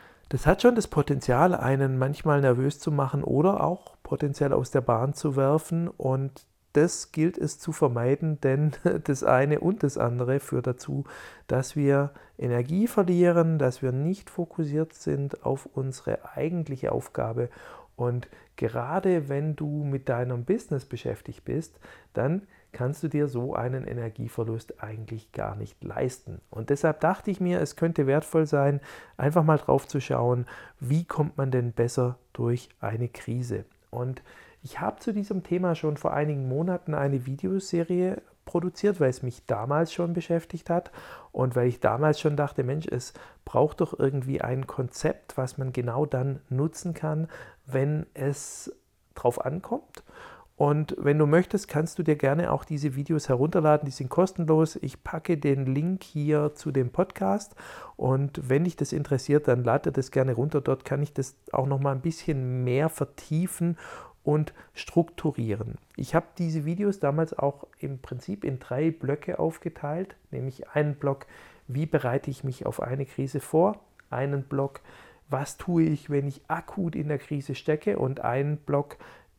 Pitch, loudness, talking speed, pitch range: 145 Hz, -27 LUFS, 160 wpm, 130-165 Hz